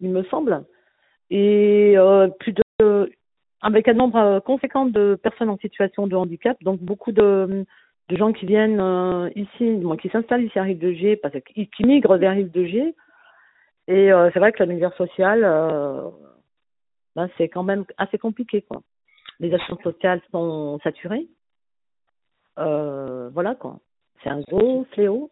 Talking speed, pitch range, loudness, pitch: 165 wpm, 180-220 Hz, -20 LUFS, 195 Hz